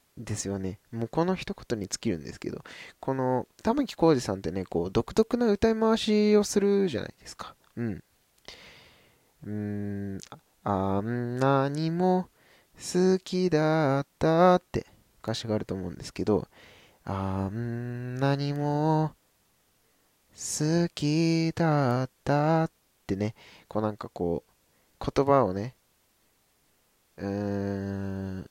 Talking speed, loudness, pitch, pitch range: 220 characters per minute, -28 LUFS, 130 Hz, 100-165 Hz